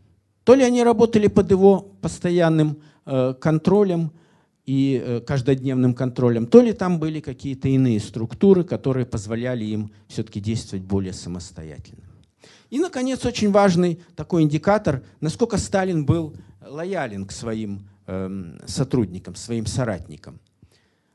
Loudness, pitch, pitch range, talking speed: -21 LUFS, 135 Hz, 110-180 Hz, 120 wpm